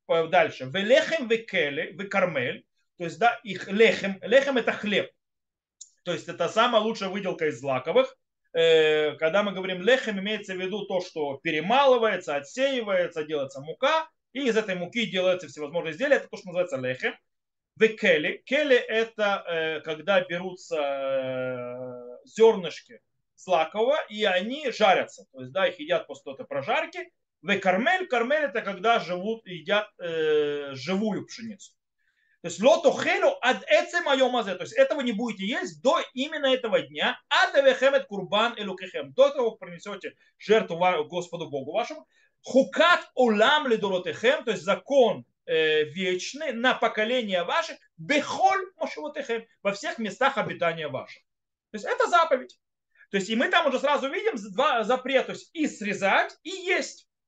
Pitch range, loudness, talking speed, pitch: 180-270 Hz, -25 LUFS, 145 wpm, 220 Hz